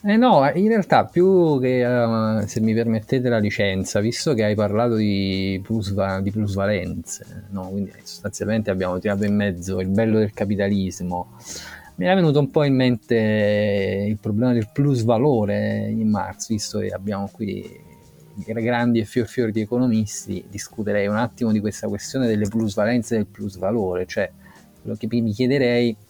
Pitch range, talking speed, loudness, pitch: 100-120 Hz, 165 wpm, -21 LUFS, 110 Hz